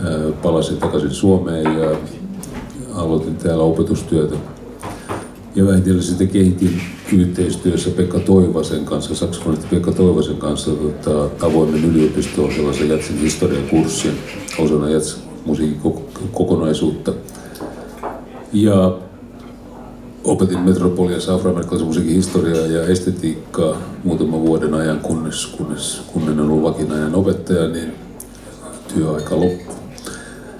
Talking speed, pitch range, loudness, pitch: 100 wpm, 75-90 Hz, -17 LUFS, 80 Hz